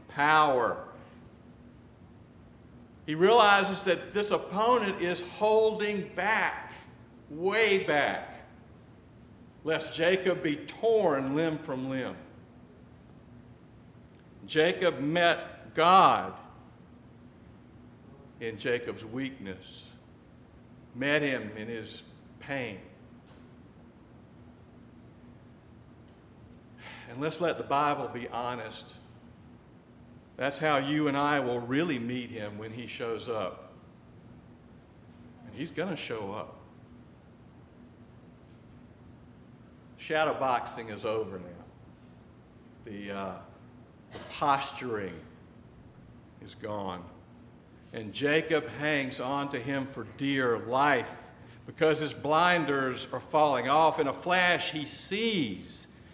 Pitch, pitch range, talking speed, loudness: 135 Hz, 120-160 Hz, 90 wpm, -29 LUFS